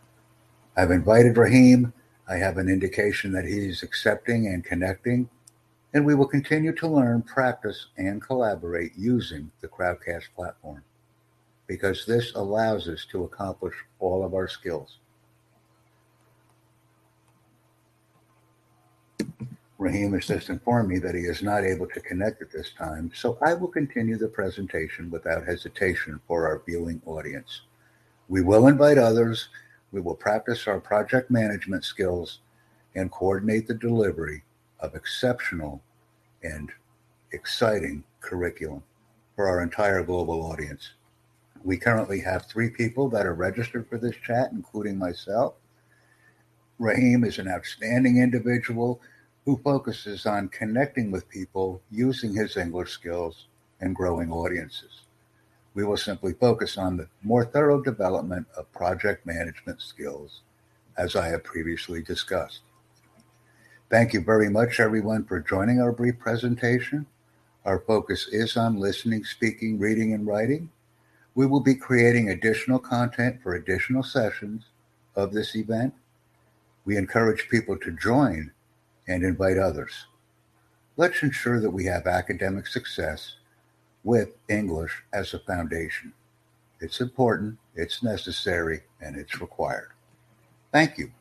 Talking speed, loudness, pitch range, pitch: 130 wpm, -25 LUFS, 95-120 Hz, 110 Hz